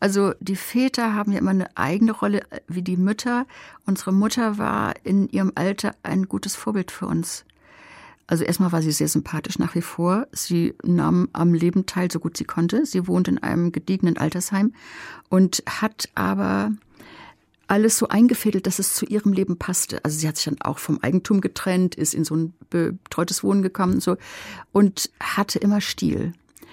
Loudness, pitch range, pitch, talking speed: -22 LUFS, 170-205 Hz, 185 Hz, 180 wpm